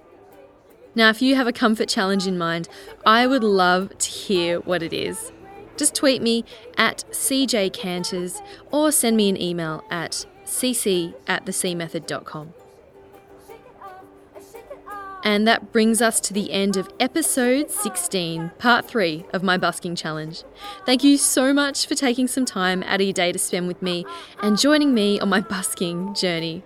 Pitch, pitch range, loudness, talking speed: 205 Hz, 180-255 Hz, -21 LUFS, 155 wpm